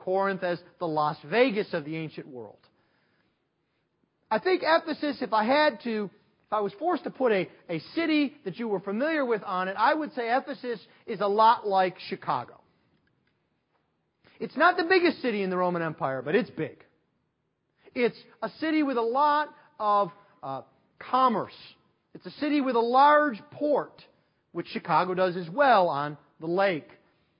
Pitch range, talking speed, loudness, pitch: 185-280 Hz, 170 wpm, -26 LUFS, 220 Hz